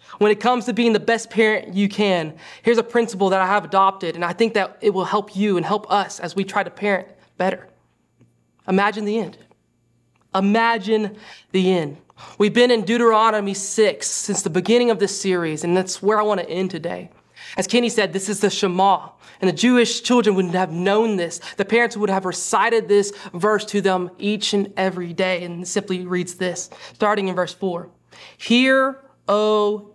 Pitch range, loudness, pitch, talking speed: 185-215 Hz, -20 LUFS, 200 Hz, 195 wpm